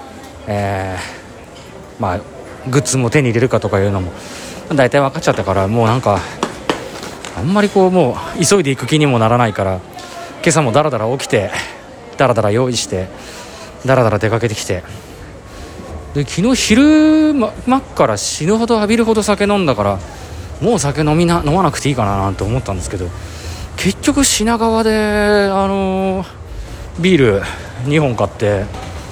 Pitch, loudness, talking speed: 125 Hz, -15 LUFS, 305 characters per minute